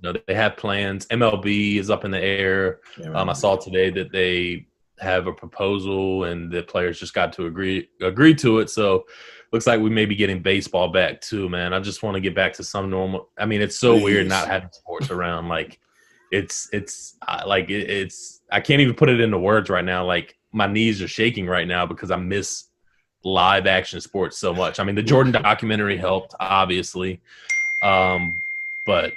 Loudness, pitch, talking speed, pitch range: -21 LUFS, 100 Hz, 195 wpm, 90-110 Hz